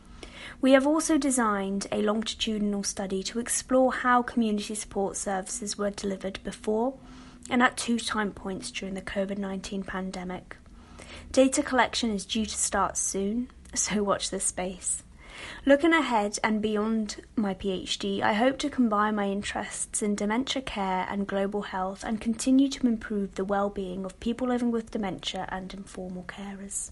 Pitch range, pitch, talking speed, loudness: 195-240 Hz, 210 Hz, 155 wpm, -28 LUFS